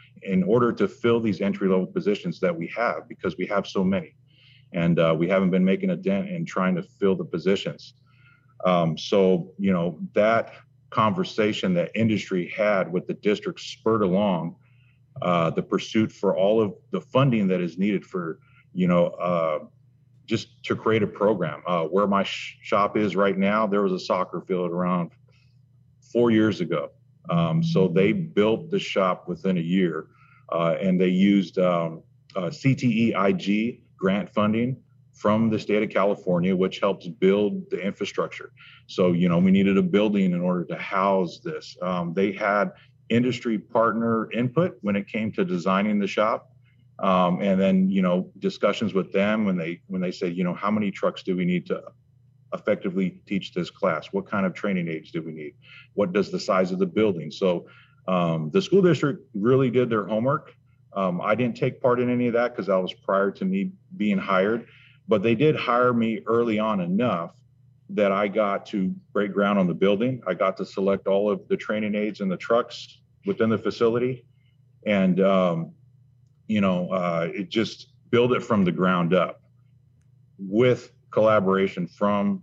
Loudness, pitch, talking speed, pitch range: -24 LUFS, 115 Hz, 180 wpm, 95-130 Hz